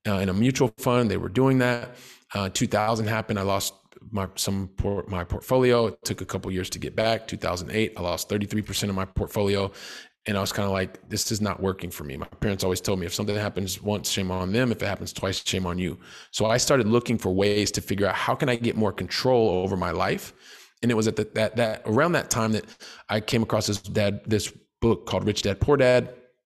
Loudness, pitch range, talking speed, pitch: -25 LUFS, 95-110 Hz, 250 wpm, 105 Hz